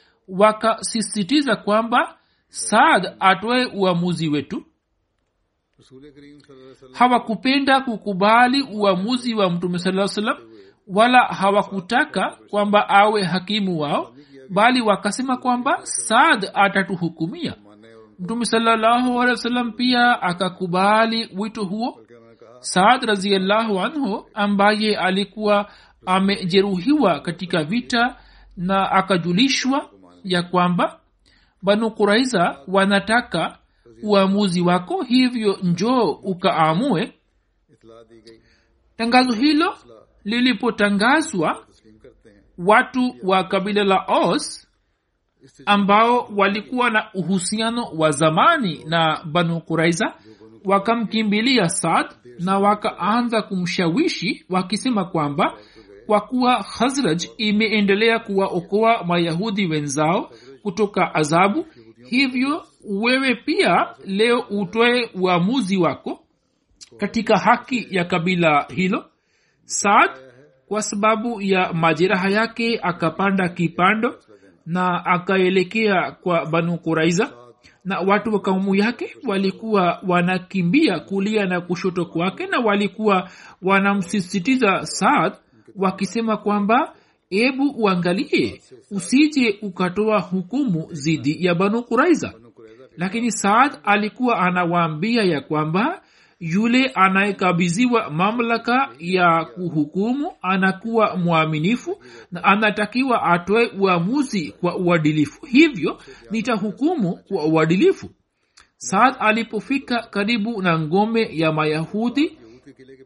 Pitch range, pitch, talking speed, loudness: 175-230 Hz, 200 Hz, 85 wpm, -19 LUFS